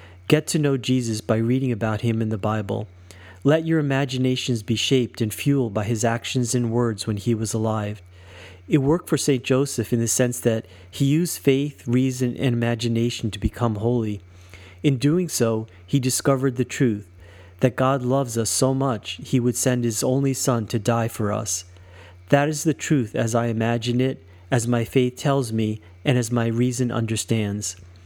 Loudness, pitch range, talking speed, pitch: -22 LUFS, 110-130 Hz, 185 wpm, 120 Hz